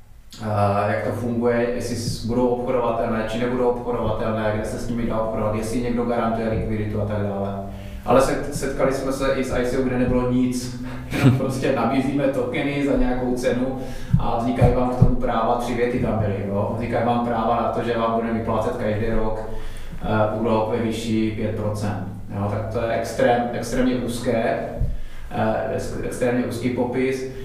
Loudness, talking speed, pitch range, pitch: -23 LUFS, 165 wpm, 110-125 Hz, 120 Hz